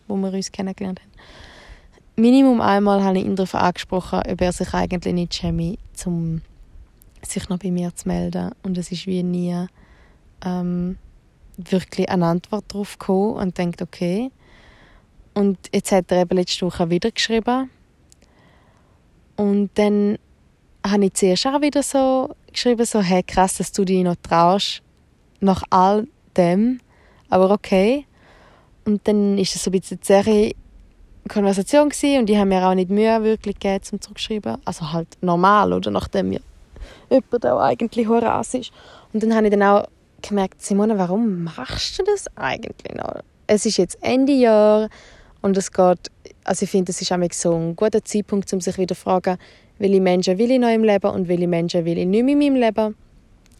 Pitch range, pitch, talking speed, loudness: 180-215 Hz, 195 Hz, 175 wpm, -20 LUFS